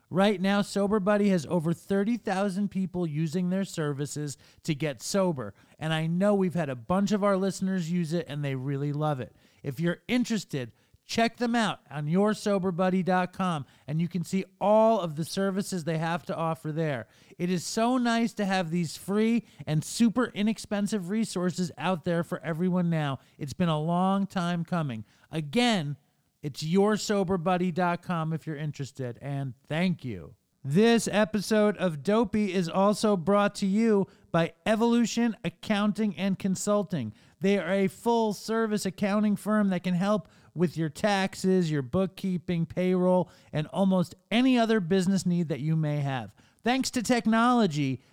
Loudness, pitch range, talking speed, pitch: -28 LUFS, 160-205 Hz, 160 wpm, 185 Hz